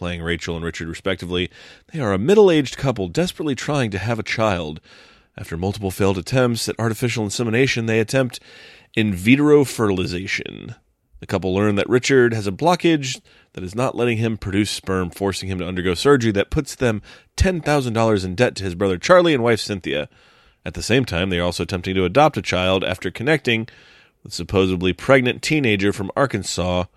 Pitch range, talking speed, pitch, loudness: 95-125 Hz, 185 wpm, 105 Hz, -20 LUFS